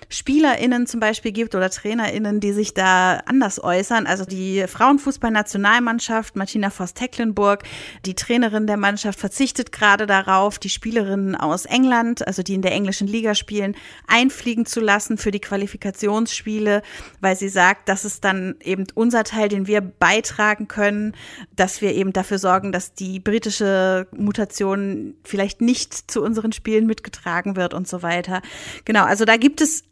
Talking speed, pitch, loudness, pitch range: 155 wpm, 205 Hz, -20 LUFS, 195-225 Hz